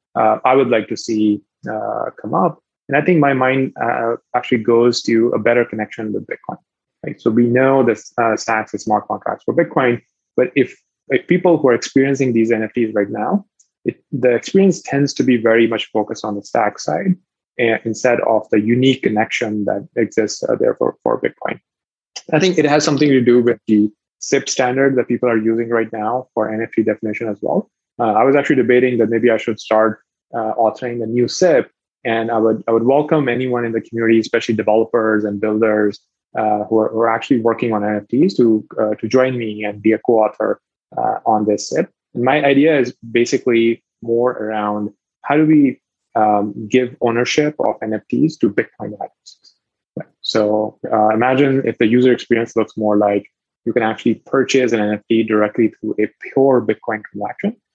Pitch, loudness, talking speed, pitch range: 115 Hz, -16 LUFS, 190 wpm, 110-130 Hz